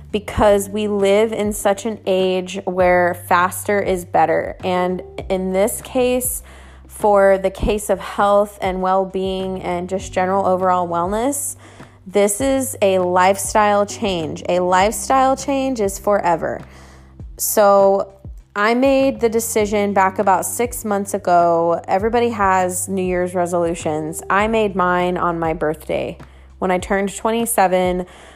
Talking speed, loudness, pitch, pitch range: 135 wpm, -18 LUFS, 195 Hz, 180-210 Hz